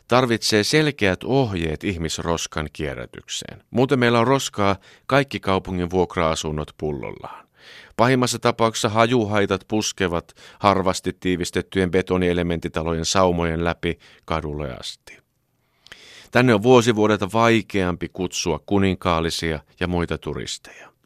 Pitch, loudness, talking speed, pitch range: 95 Hz, -21 LUFS, 95 wpm, 85-115 Hz